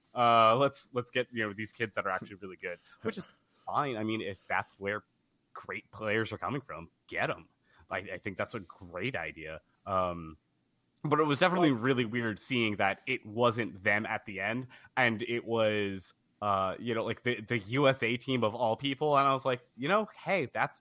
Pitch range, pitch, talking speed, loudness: 105-130 Hz, 115 Hz, 210 wpm, -31 LUFS